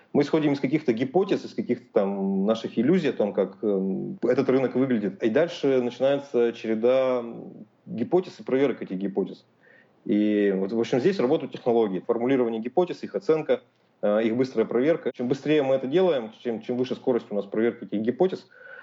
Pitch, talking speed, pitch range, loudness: 125 Hz, 170 wpm, 110-140 Hz, -25 LUFS